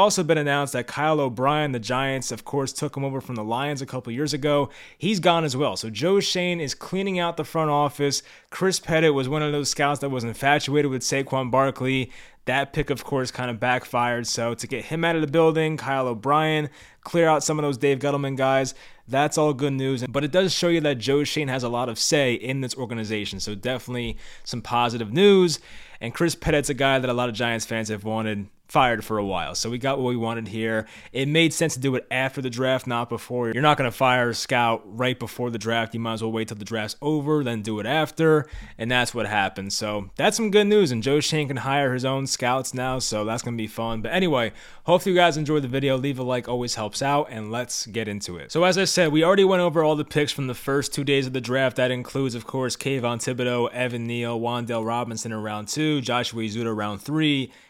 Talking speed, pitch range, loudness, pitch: 245 wpm, 120-150 Hz, -23 LUFS, 130 Hz